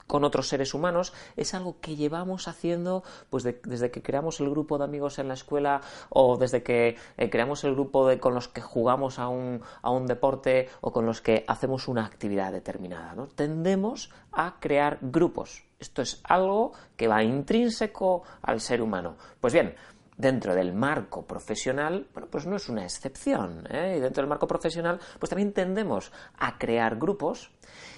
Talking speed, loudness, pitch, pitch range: 180 wpm, -28 LUFS, 140 Hz, 125-175 Hz